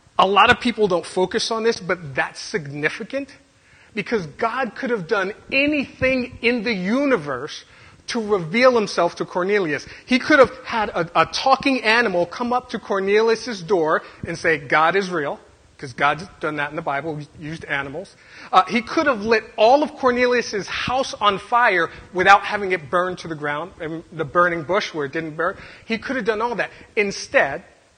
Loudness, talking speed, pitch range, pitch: -20 LUFS, 185 wpm, 170-245 Hz, 210 Hz